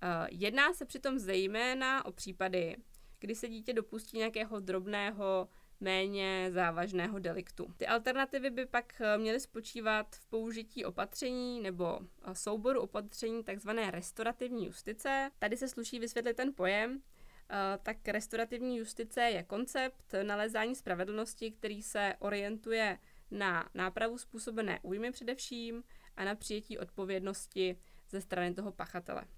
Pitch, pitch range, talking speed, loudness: 220 Hz, 195-235 Hz, 120 wpm, -37 LUFS